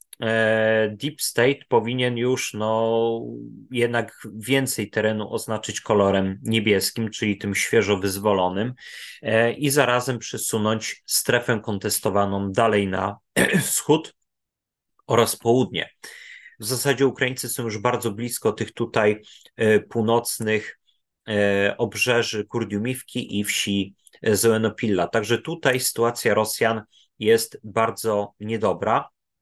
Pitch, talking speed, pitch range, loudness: 110 Hz, 95 wpm, 105-120 Hz, -22 LUFS